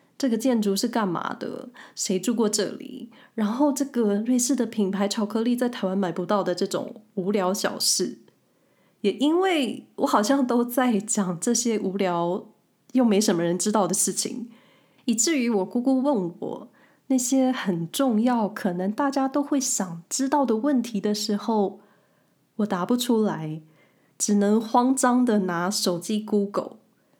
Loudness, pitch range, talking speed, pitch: -24 LUFS, 195-255 Hz, 240 characters per minute, 220 Hz